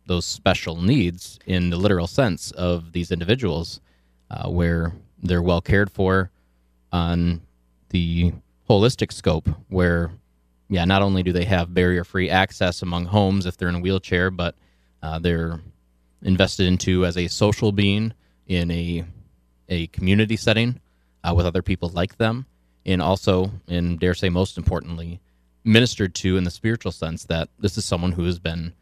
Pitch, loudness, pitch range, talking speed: 90 Hz, -22 LUFS, 85-95 Hz, 160 wpm